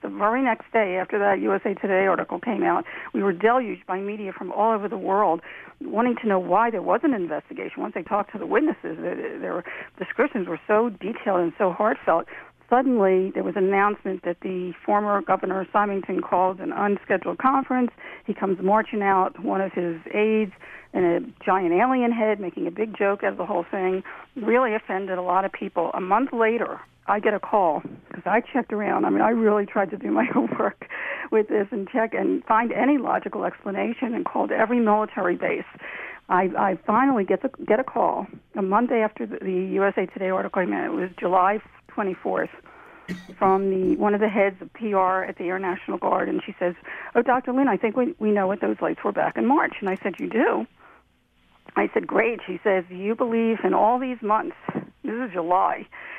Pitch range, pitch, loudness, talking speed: 185-225 Hz, 200 Hz, -24 LUFS, 205 wpm